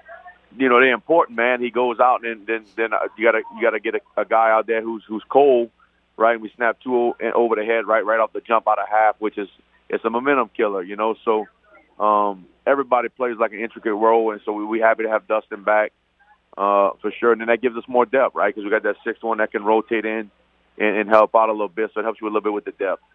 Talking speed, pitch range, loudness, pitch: 270 wpm, 105-115 Hz, -20 LUFS, 110 Hz